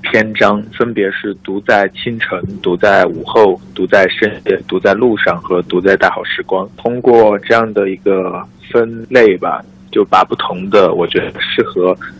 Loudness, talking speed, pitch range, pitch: -13 LUFS, 235 characters per minute, 95-115 Hz, 105 Hz